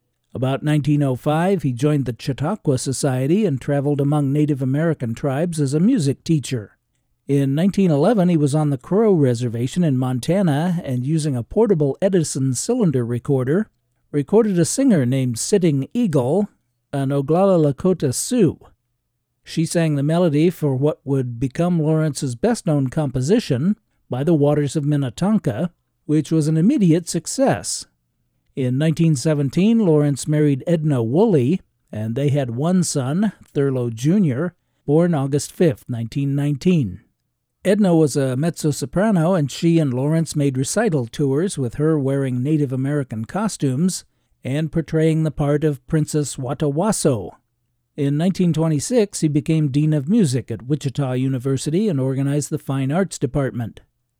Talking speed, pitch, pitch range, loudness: 135 wpm, 150 Hz, 135-170 Hz, -19 LUFS